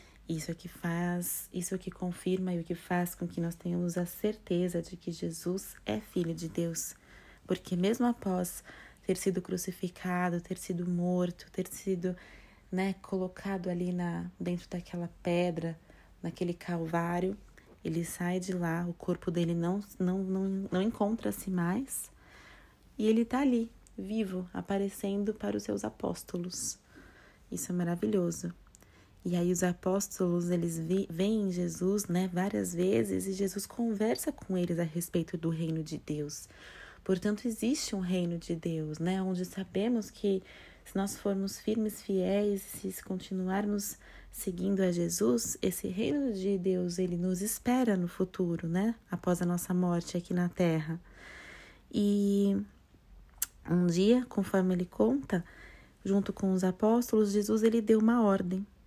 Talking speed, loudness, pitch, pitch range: 145 wpm, -33 LUFS, 185 Hz, 175-200 Hz